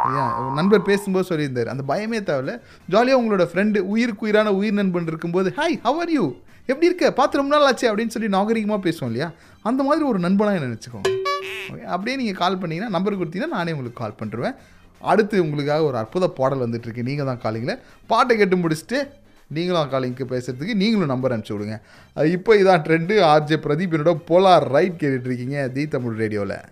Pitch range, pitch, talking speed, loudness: 135-215 Hz, 175 Hz, 170 wpm, -21 LUFS